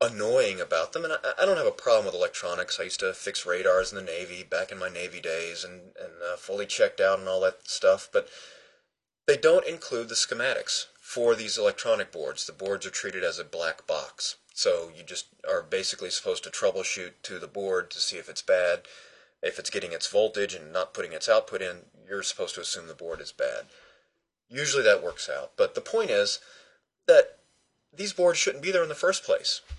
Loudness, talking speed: -27 LUFS, 215 wpm